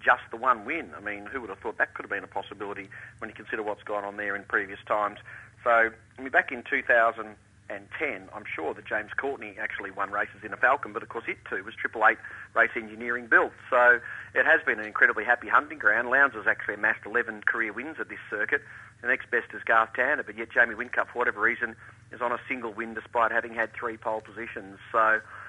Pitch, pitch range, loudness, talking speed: 115 Hz, 105-120 Hz, -27 LUFS, 240 wpm